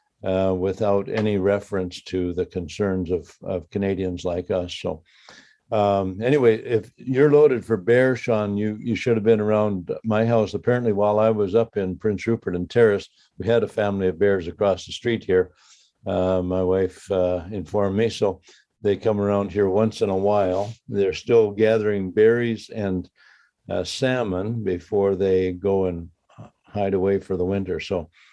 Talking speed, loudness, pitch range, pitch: 170 wpm, -22 LUFS, 95-110 Hz, 100 Hz